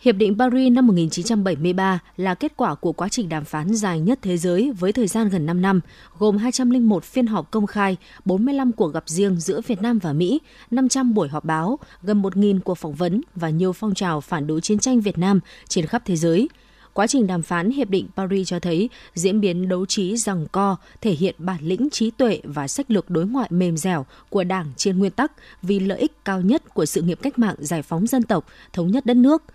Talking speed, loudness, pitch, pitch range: 225 wpm, -21 LUFS, 195 Hz, 175-235 Hz